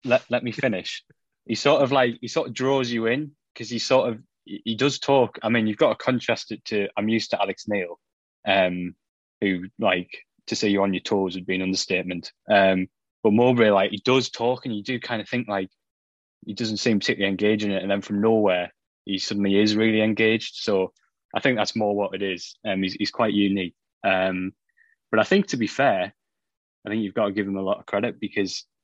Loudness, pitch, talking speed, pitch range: -23 LUFS, 105 Hz, 230 wpm, 95-120 Hz